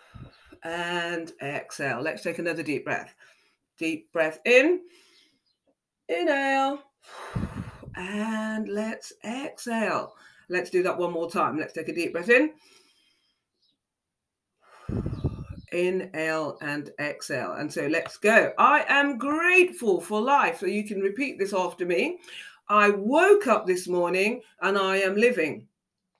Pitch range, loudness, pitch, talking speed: 175-280 Hz, -25 LUFS, 210 Hz, 125 wpm